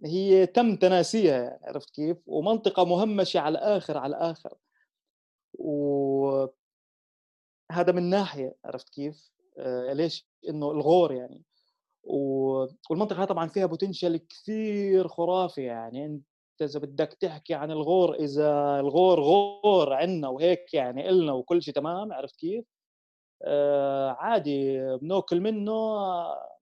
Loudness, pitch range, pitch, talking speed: -26 LUFS, 145-190 Hz, 170 Hz, 115 wpm